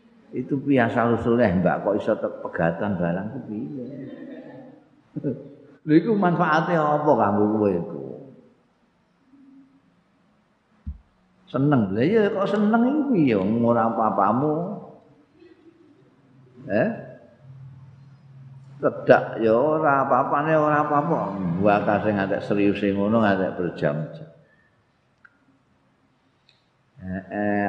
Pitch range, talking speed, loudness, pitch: 105-155 Hz, 85 wpm, -22 LUFS, 135 Hz